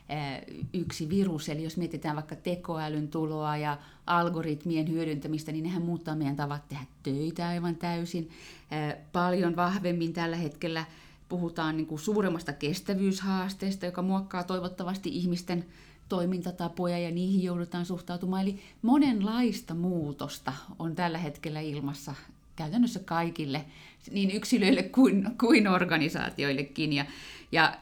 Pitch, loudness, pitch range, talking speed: 170 Hz, -30 LUFS, 155-180 Hz, 110 wpm